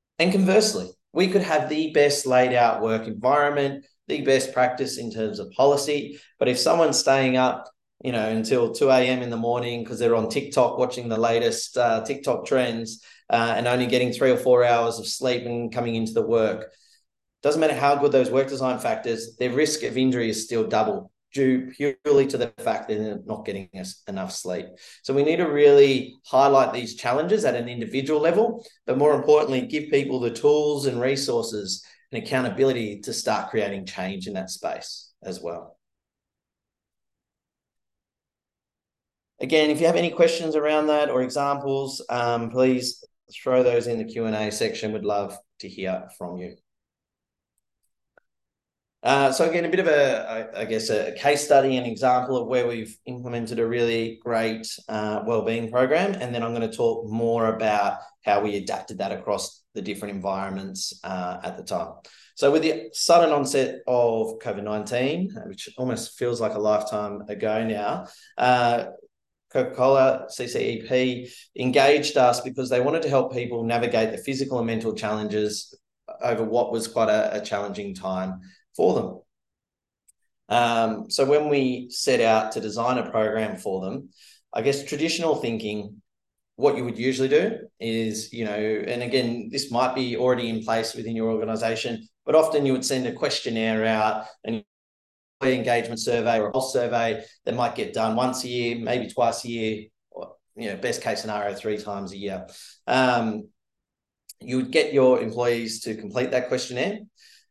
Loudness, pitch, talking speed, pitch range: -23 LUFS, 120 Hz, 170 wpm, 110-135 Hz